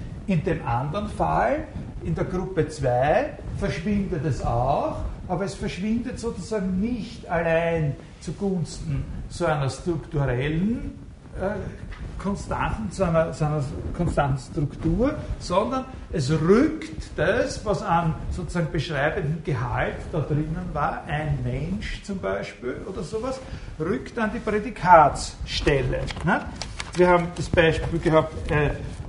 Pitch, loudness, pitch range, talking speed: 170 Hz, -25 LUFS, 150-195 Hz, 120 wpm